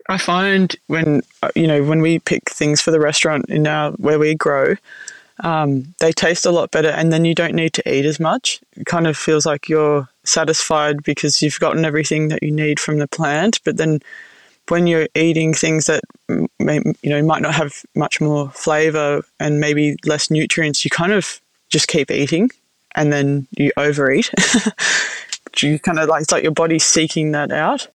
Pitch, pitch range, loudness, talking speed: 155 Hz, 150-165 Hz, -17 LUFS, 195 wpm